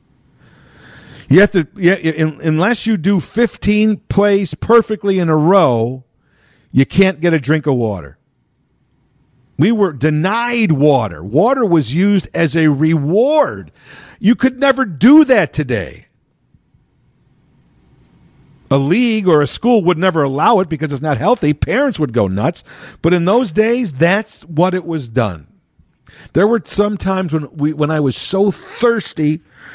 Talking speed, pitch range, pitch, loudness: 145 wpm, 145-205 Hz, 170 Hz, -14 LUFS